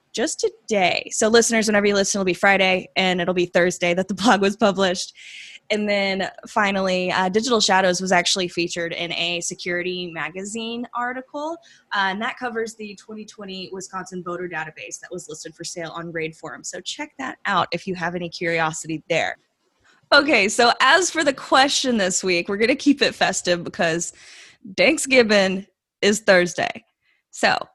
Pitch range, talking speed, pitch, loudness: 175-230 Hz, 170 wpm, 190 Hz, -20 LUFS